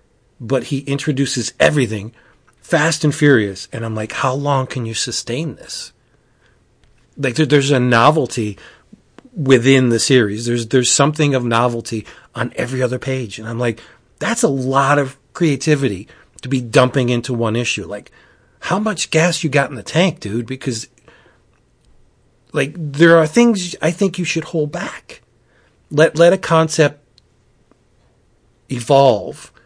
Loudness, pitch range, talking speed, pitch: -16 LUFS, 120-155 Hz, 150 wpm, 130 Hz